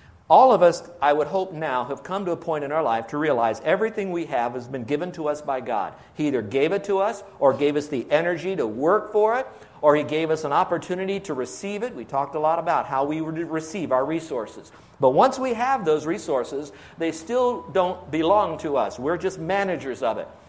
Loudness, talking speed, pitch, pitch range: -23 LUFS, 230 wpm, 160 Hz, 145-190 Hz